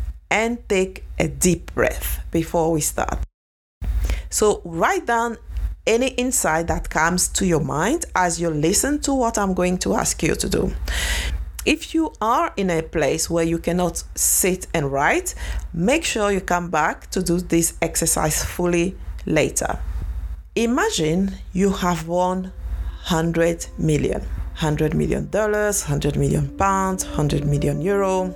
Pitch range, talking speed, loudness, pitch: 155-205 Hz, 145 wpm, -21 LUFS, 175 Hz